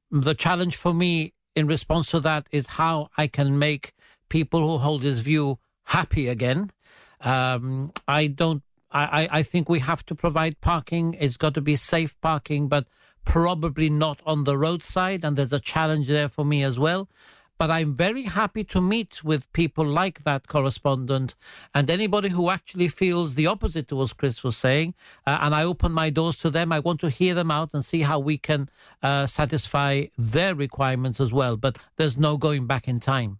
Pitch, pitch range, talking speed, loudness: 155 Hz, 140-165 Hz, 190 wpm, -24 LUFS